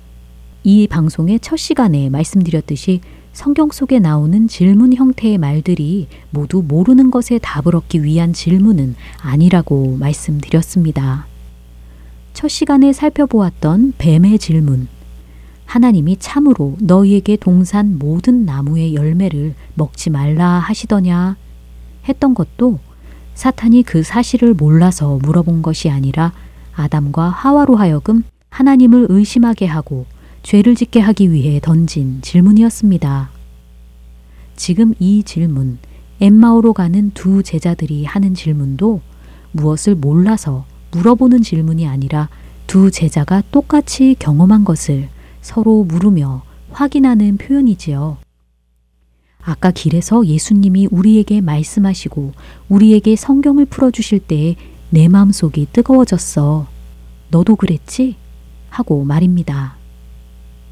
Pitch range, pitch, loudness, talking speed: 145-215 Hz, 170 Hz, -12 LUFS, 265 characters per minute